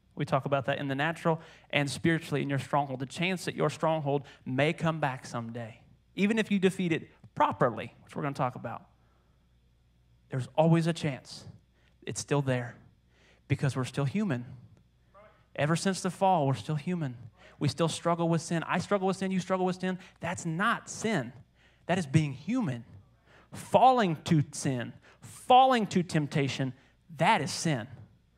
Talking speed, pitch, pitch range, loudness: 170 wpm, 150 Hz, 130-170 Hz, -29 LUFS